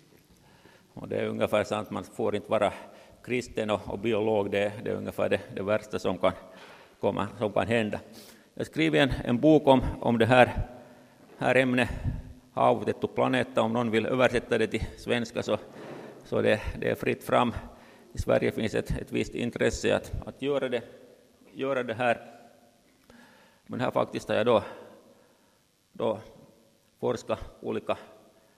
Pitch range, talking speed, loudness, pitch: 105-125 Hz, 165 wpm, -28 LUFS, 115 Hz